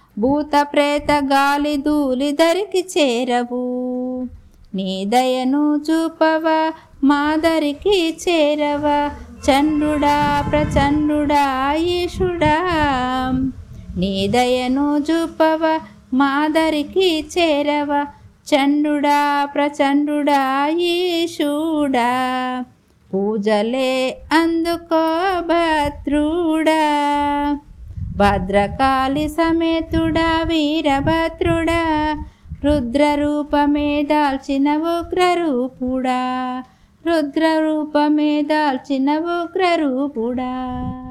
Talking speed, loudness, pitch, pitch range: 55 wpm, -18 LUFS, 295 Hz, 270-320 Hz